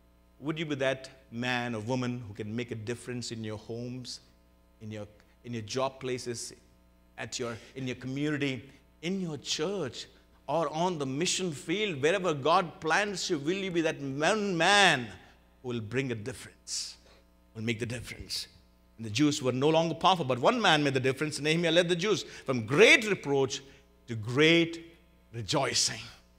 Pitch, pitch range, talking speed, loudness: 125 Hz, 110-155 Hz, 175 wpm, -29 LUFS